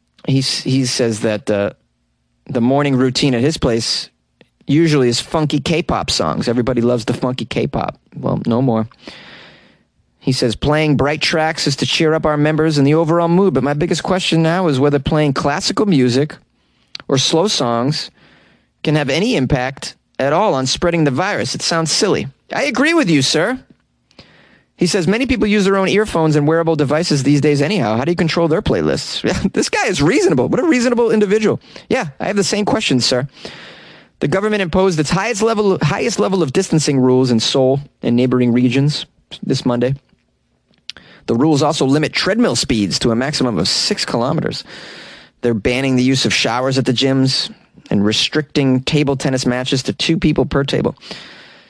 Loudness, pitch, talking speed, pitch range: -15 LUFS, 145 Hz, 180 wpm, 130-165 Hz